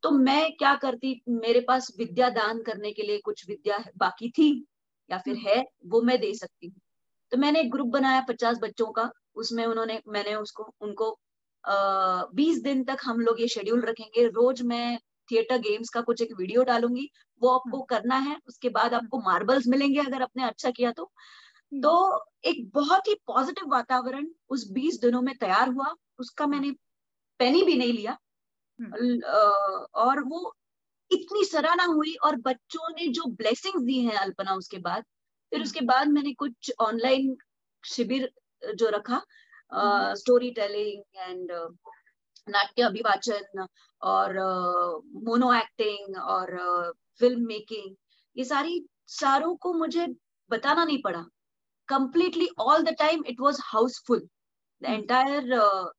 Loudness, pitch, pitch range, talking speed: -26 LUFS, 250 Hz, 225-285 Hz, 145 wpm